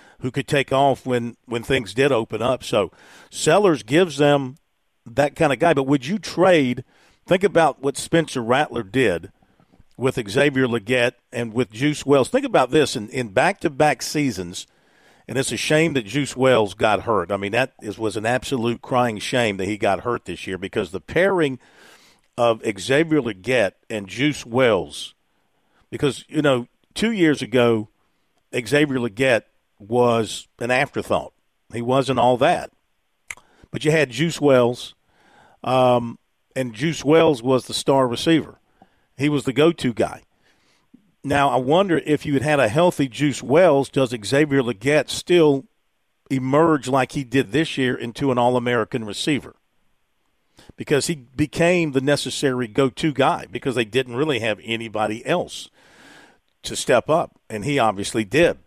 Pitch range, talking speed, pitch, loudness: 120-145 Hz, 160 wpm, 130 Hz, -20 LUFS